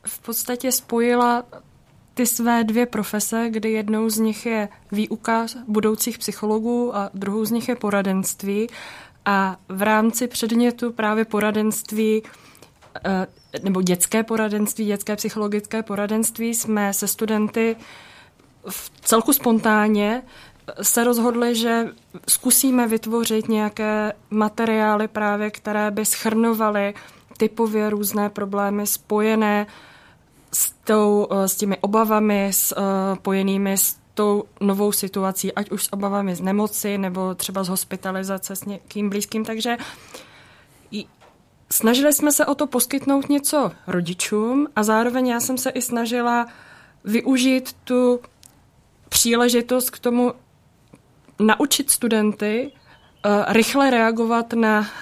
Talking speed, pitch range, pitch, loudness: 110 wpm, 205-235 Hz, 215 Hz, -21 LUFS